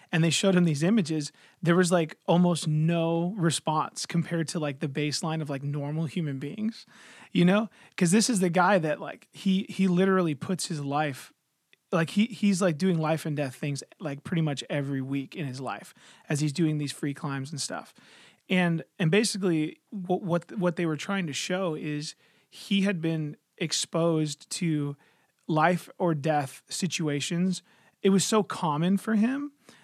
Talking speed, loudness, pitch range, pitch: 180 wpm, -27 LUFS, 150-190 Hz, 170 Hz